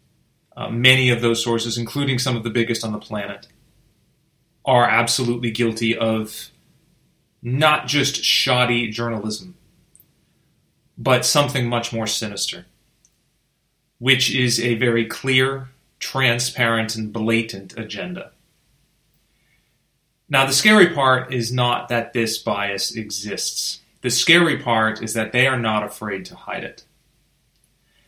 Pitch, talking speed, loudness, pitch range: 120 Hz, 120 wpm, -19 LUFS, 115-135 Hz